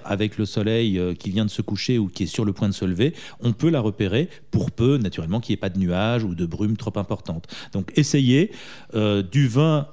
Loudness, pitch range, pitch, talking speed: -23 LUFS, 100-125 Hz, 110 Hz, 250 wpm